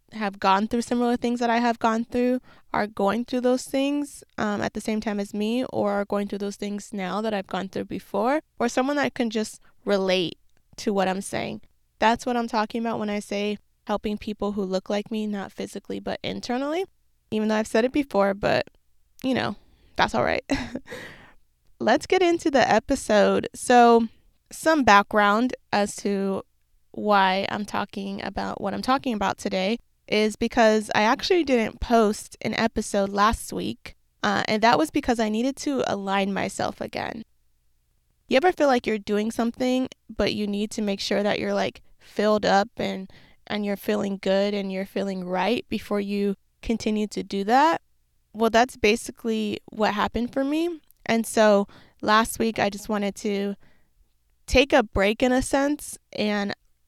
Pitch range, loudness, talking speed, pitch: 200-240 Hz, -24 LUFS, 180 wpm, 215 Hz